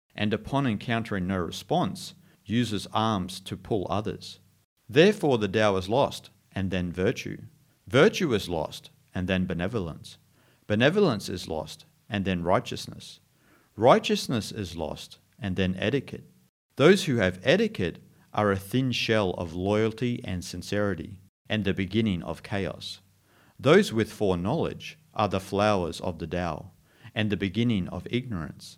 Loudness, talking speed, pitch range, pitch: -27 LUFS, 140 wpm, 95-120 Hz, 100 Hz